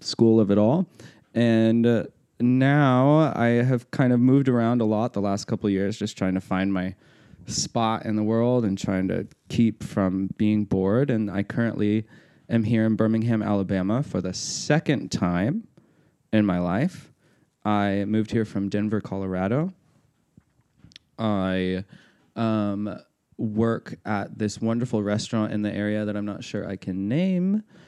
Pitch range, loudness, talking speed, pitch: 100-120 Hz, -24 LUFS, 155 wpm, 110 Hz